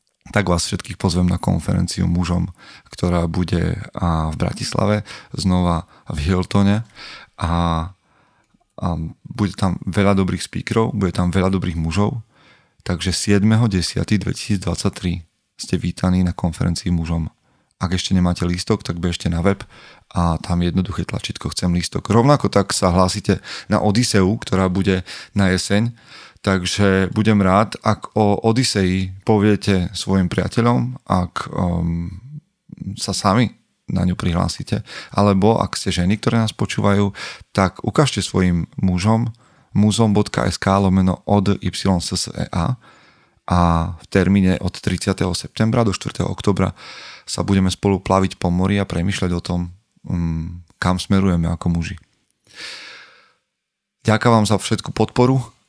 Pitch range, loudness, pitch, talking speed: 90-105 Hz, -19 LUFS, 95 Hz, 125 wpm